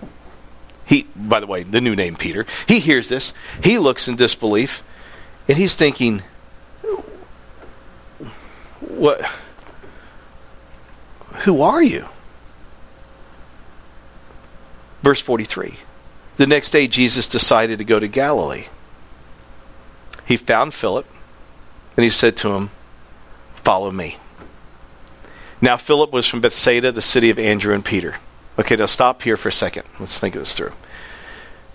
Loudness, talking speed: -16 LUFS, 125 wpm